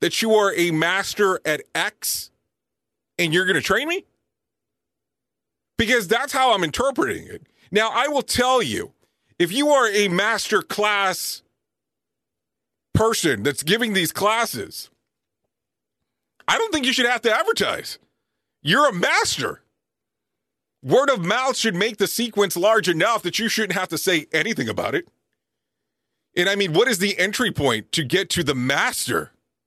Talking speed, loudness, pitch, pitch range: 155 wpm, -20 LUFS, 215 Hz, 185-240 Hz